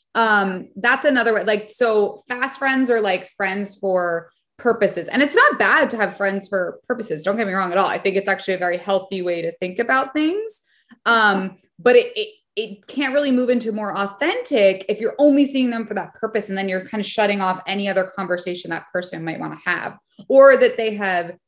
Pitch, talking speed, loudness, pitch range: 205 Hz, 220 wpm, -19 LUFS, 190-250 Hz